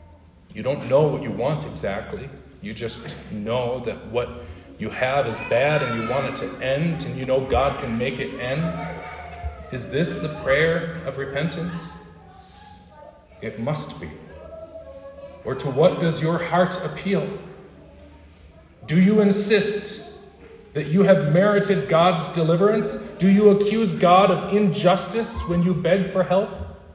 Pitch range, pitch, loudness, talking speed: 130-195 Hz, 170 Hz, -21 LUFS, 145 wpm